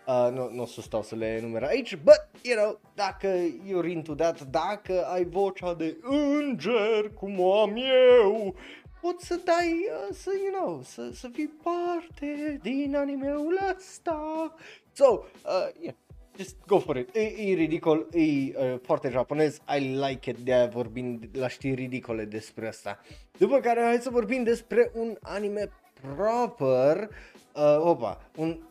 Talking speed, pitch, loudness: 155 wpm, 195 Hz, -27 LUFS